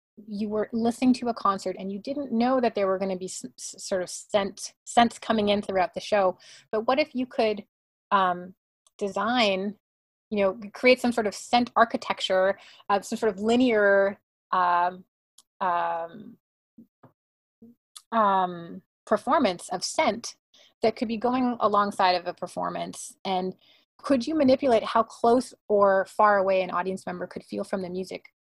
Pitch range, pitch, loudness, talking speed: 190-235 Hz, 205 Hz, -25 LUFS, 160 wpm